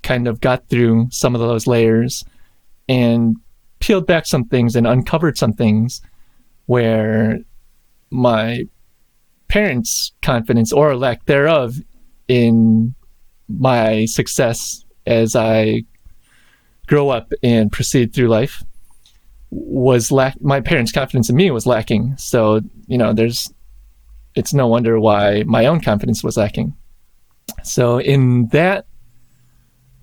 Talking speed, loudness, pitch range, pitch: 120 wpm, -16 LUFS, 110-130 Hz, 120 Hz